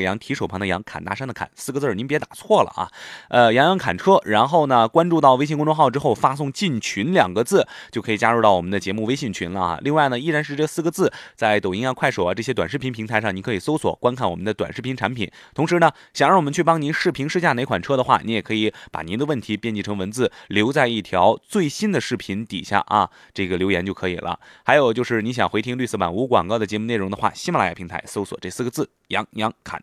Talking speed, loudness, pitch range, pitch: 385 characters per minute, -21 LUFS, 105-150 Hz, 120 Hz